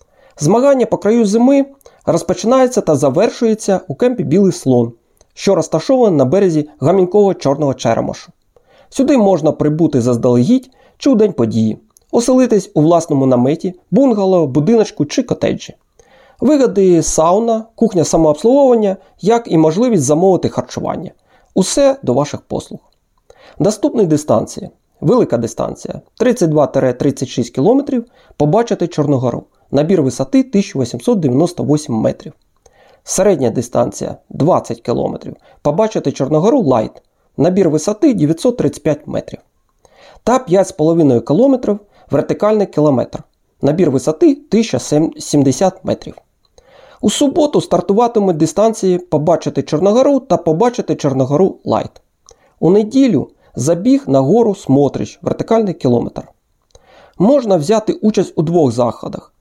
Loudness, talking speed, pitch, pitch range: -14 LUFS, 105 wpm, 185 Hz, 150-225 Hz